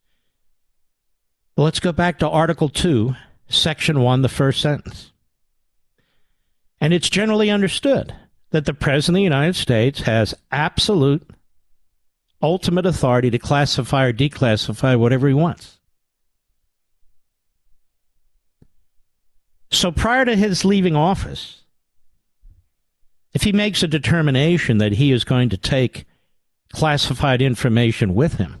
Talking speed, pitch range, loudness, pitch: 115 wpm, 105-160 Hz, -18 LUFS, 130 Hz